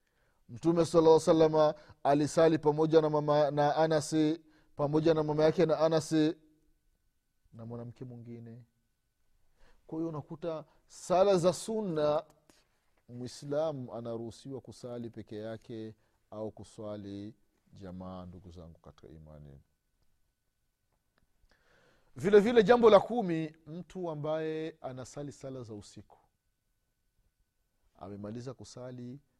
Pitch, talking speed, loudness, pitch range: 145 Hz, 95 wpm, -29 LUFS, 115-160 Hz